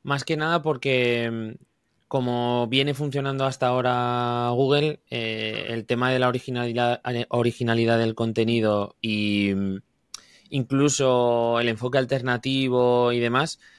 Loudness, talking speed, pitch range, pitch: -23 LUFS, 115 wpm, 115-135 Hz, 120 Hz